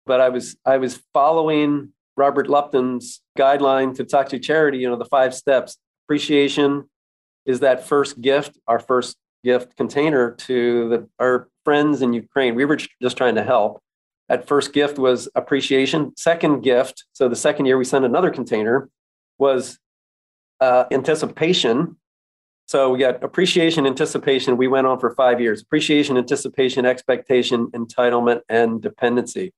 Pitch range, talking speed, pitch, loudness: 125-145 Hz, 150 wpm, 130 Hz, -19 LUFS